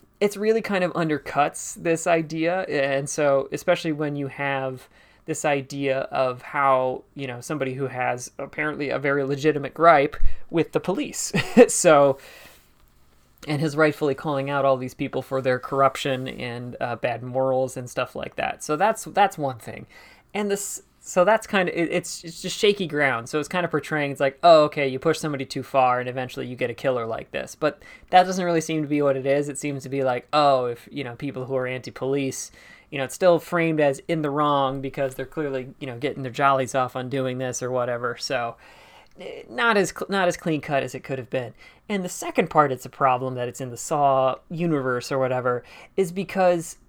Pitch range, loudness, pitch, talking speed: 130-160 Hz, -23 LUFS, 140 Hz, 205 wpm